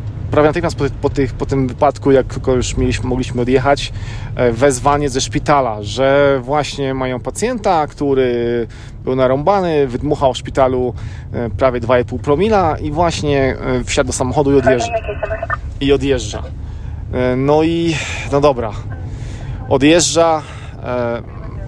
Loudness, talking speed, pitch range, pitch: -16 LUFS, 125 wpm, 115-140 Hz, 130 Hz